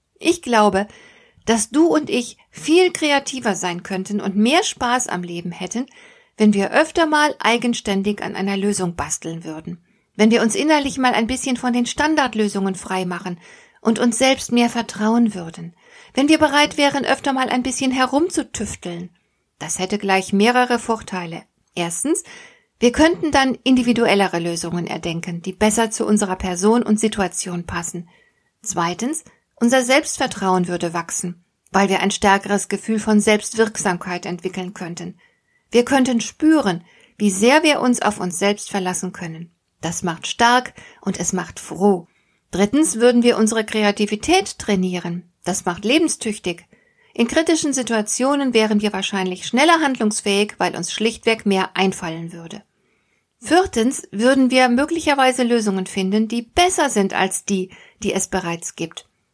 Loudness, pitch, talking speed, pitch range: -19 LUFS, 215 Hz, 145 wpm, 185-255 Hz